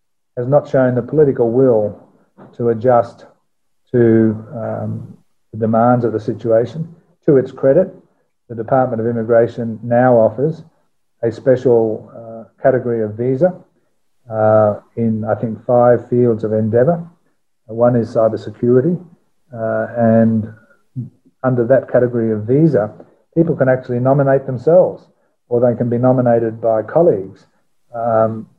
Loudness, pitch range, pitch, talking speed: -15 LUFS, 110-130 Hz, 120 Hz, 130 wpm